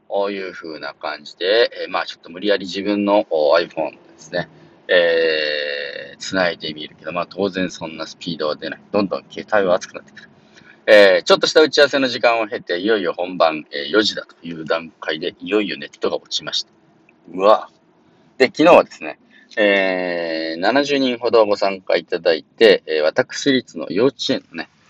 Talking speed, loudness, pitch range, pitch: 340 characters per minute, -18 LUFS, 85-135 Hz, 100 Hz